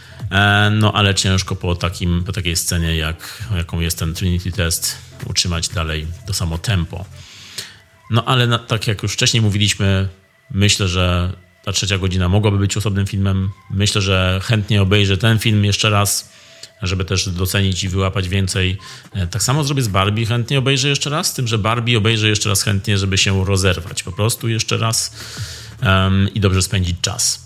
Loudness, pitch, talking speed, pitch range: -17 LUFS, 100 Hz, 175 wpm, 95-110 Hz